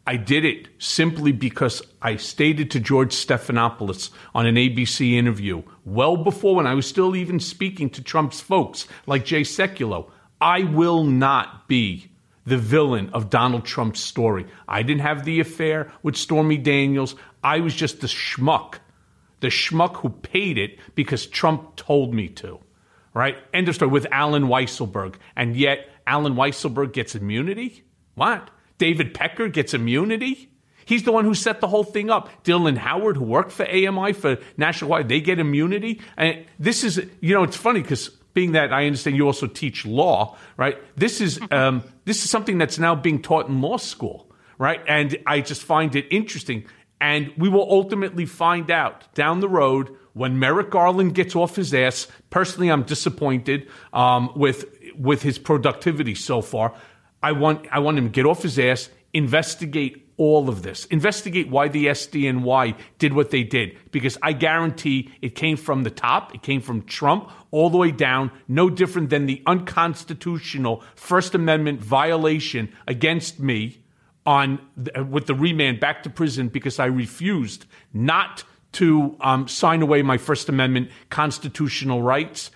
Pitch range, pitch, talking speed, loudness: 130-165 Hz, 145 Hz, 170 wpm, -21 LUFS